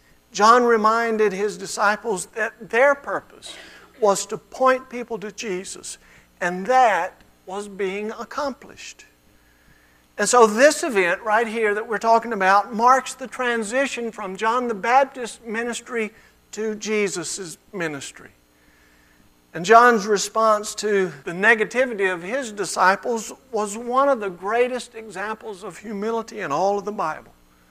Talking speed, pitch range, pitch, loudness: 130 wpm, 195-235 Hz, 215 Hz, -21 LUFS